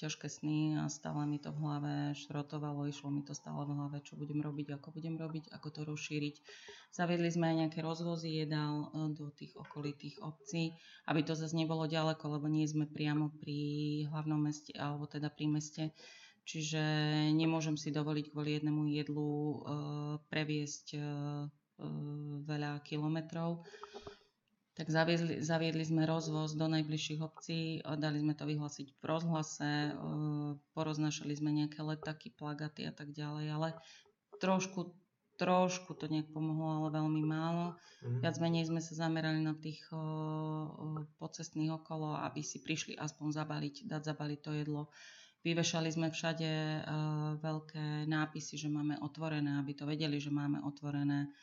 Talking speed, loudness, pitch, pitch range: 145 wpm, -38 LUFS, 155 Hz, 150-160 Hz